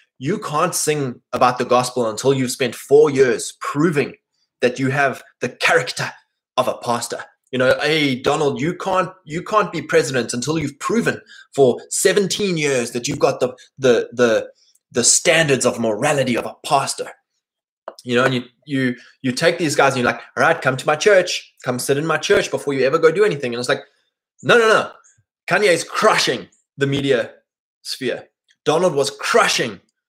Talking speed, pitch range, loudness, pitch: 185 wpm, 125-185 Hz, -18 LUFS, 145 Hz